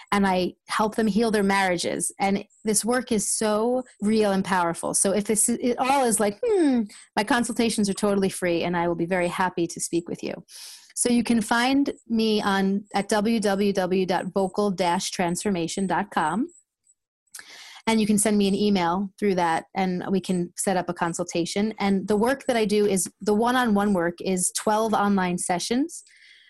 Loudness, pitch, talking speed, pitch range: -24 LUFS, 205 Hz, 170 wpm, 185-225 Hz